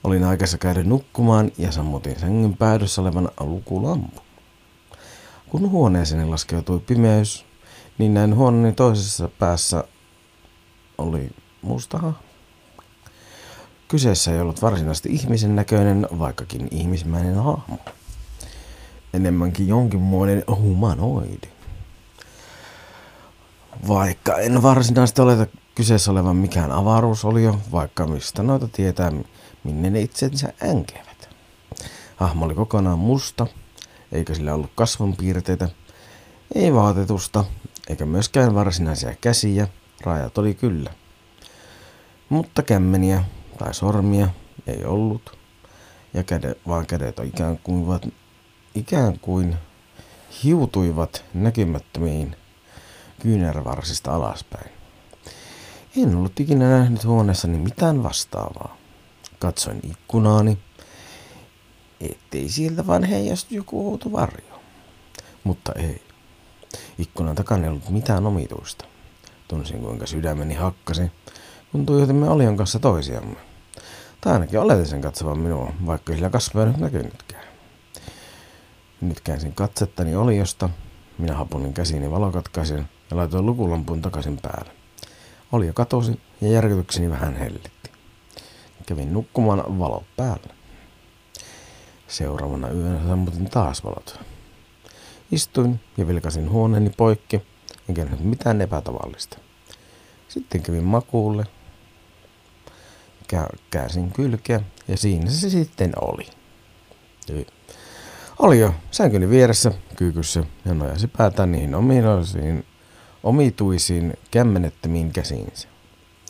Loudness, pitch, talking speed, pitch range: -21 LUFS, 95 Hz, 100 wpm, 85-110 Hz